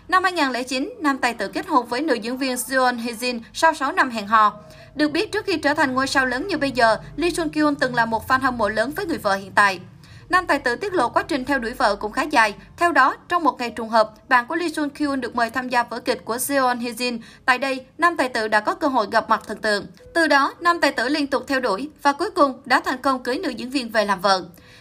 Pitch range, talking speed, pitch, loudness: 230-300 Hz, 275 wpm, 260 Hz, -21 LUFS